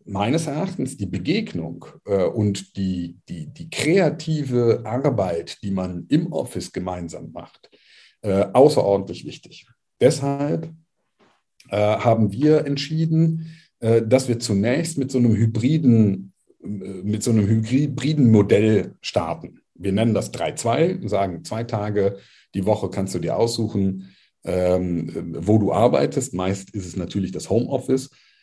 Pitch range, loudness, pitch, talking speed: 95-135 Hz, -21 LUFS, 110 Hz, 135 wpm